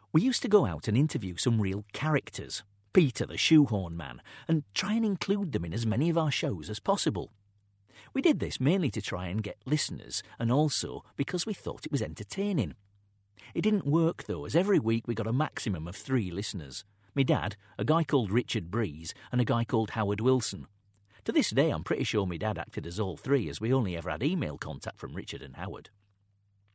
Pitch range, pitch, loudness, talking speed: 100-150 Hz, 110 Hz, -30 LUFS, 210 wpm